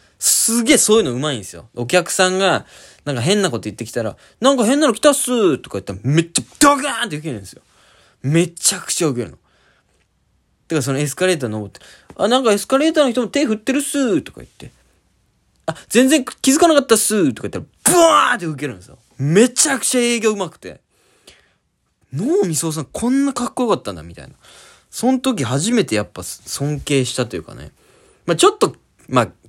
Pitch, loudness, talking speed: 185 Hz, -17 LUFS, 435 characters per minute